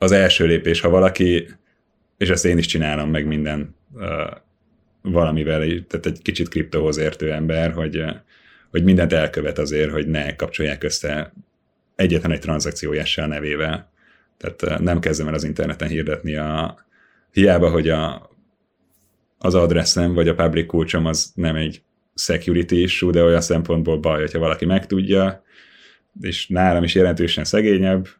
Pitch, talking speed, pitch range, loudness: 85 Hz, 140 wpm, 80-90 Hz, -19 LUFS